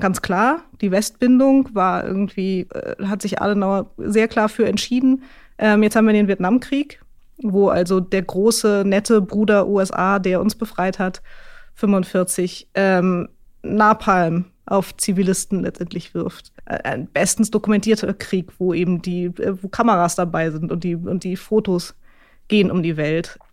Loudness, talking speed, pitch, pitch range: -19 LUFS, 150 wpm, 195 Hz, 185-215 Hz